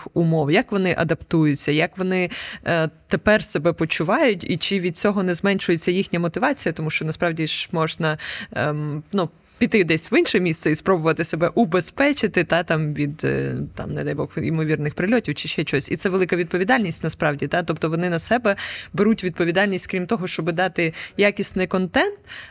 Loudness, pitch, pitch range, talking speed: -21 LUFS, 175 Hz, 160-195 Hz, 175 wpm